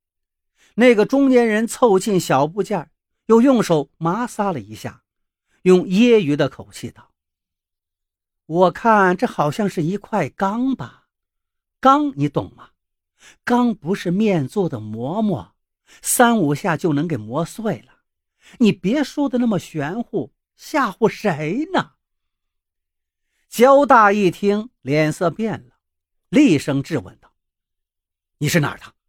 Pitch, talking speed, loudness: 170 Hz, 175 characters per minute, -18 LUFS